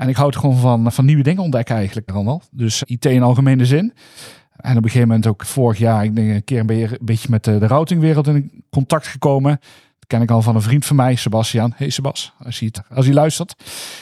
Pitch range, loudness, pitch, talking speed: 115-140 Hz, -16 LUFS, 125 Hz, 235 wpm